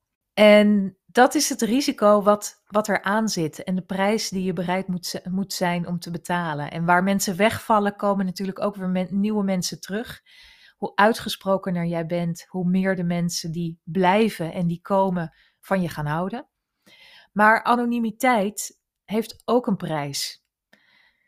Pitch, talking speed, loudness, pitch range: 195 Hz, 160 wpm, -22 LUFS, 175-215 Hz